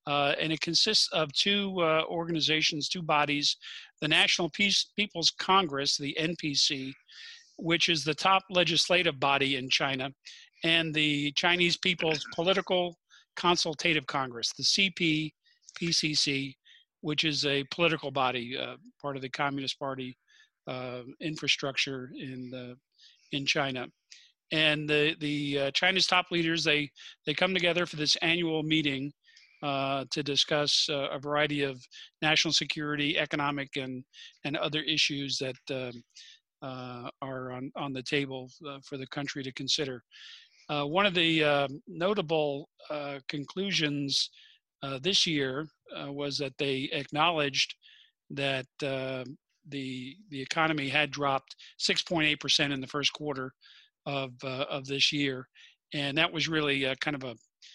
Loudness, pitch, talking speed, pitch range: -28 LUFS, 150 Hz, 145 wpm, 140-165 Hz